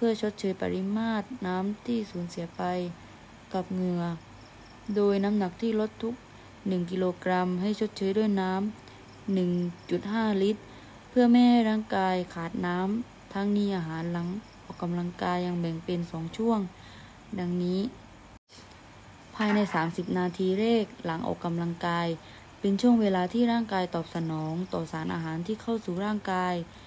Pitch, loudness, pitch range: 185 Hz, -29 LUFS, 175-210 Hz